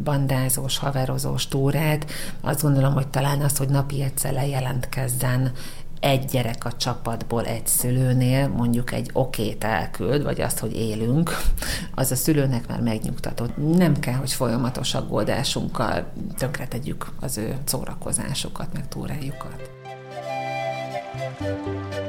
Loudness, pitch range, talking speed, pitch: -24 LUFS, 120-140 Hz, 115 wpm, 130 Hz